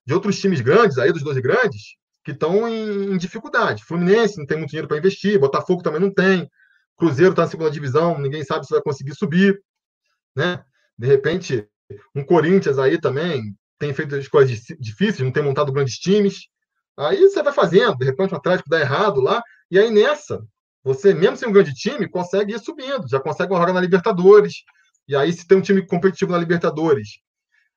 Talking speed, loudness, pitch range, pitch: 195 wpm, -18 LUFS, 150-200 Hz, 180 Hz